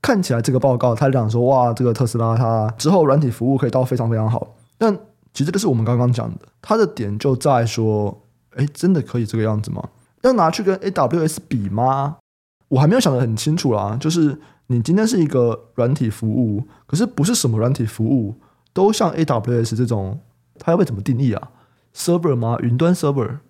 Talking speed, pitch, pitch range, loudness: 330 characters per minute, 125 Hz, 115-155 Hz, -19 LUFS